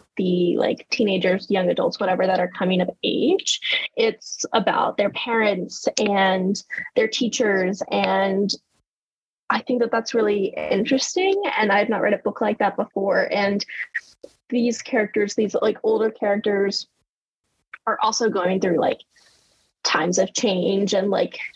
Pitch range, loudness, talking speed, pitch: 190-230 Hz, -21 LUFS, 140 wpm, 205 Hz